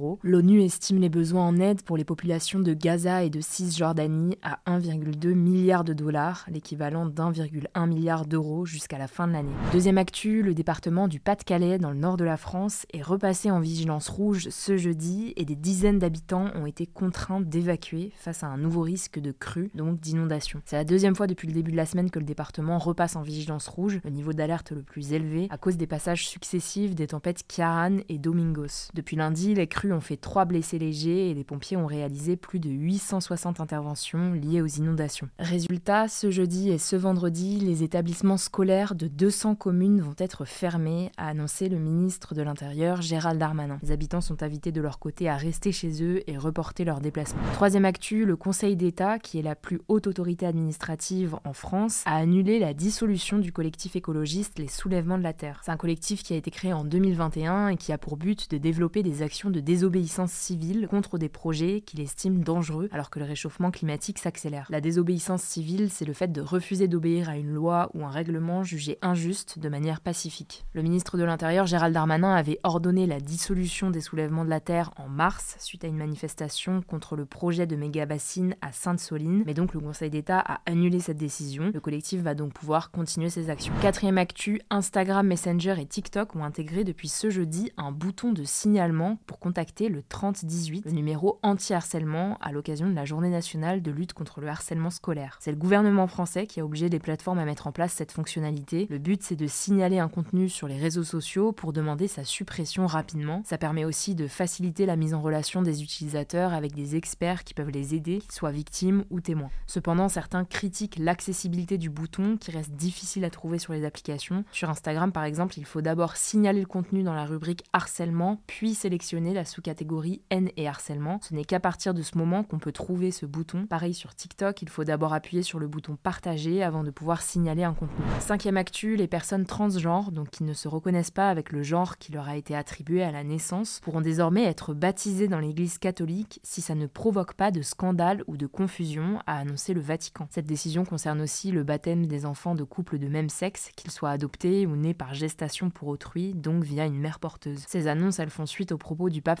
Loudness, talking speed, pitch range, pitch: -28 LUFS, 205 wpm, 155-185 Hz, 170 Hz